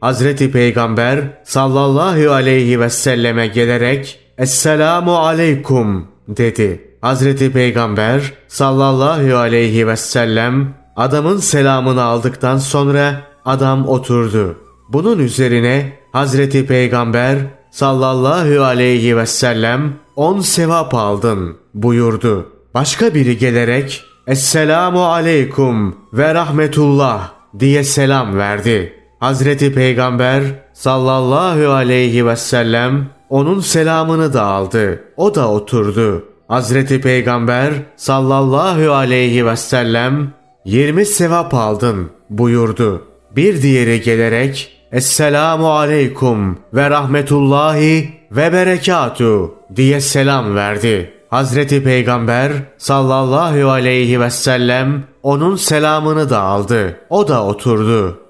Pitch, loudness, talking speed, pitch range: 130 Hz, -13 LUFS, 95 wpm, 120-145 Hz